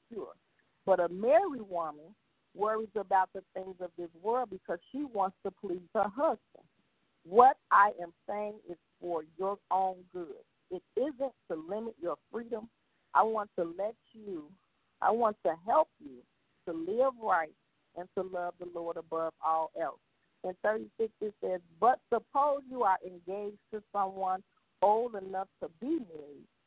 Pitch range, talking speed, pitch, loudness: 180-225 Hz, 155 wpm, 200 Hz, -33 LUFS